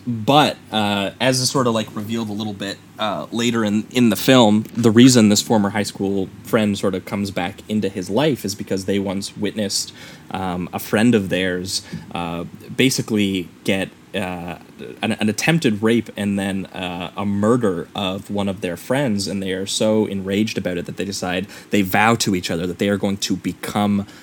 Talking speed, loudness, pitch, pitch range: 200 wpm, -20 LUFS, 100 Hz, 95-110 Hz